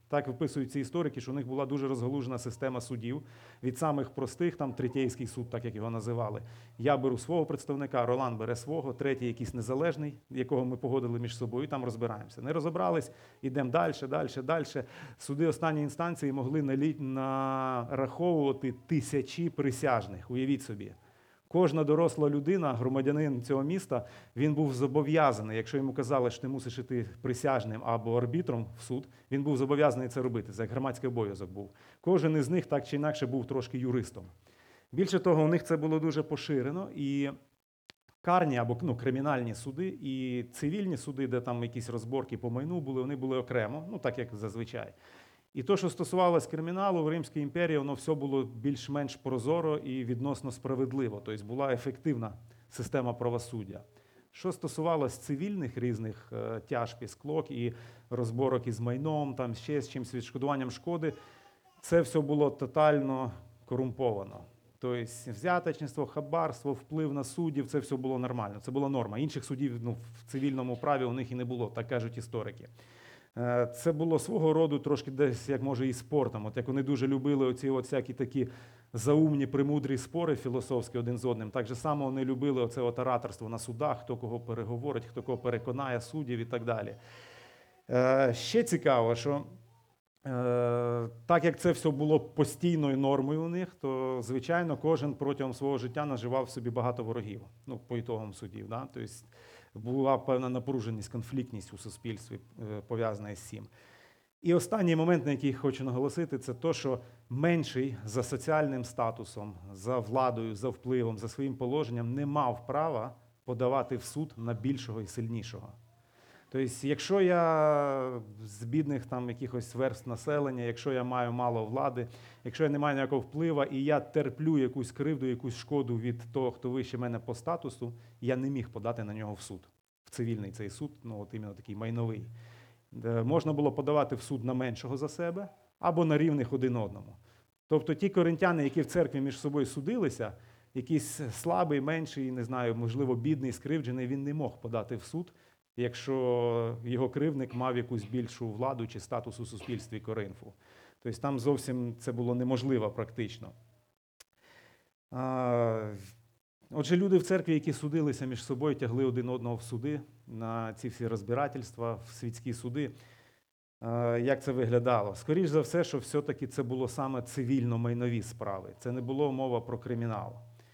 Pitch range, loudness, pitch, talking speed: 120-145 Hz, -33 LUFS, 130 Hz, 160 wpm